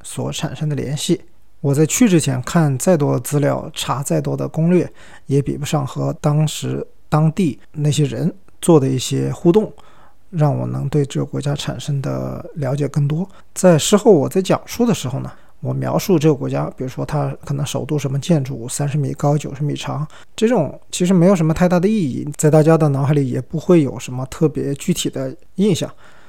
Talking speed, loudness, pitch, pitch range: 290 characters per minute, -18 LUFS, 150 Hz, 135-165 Hz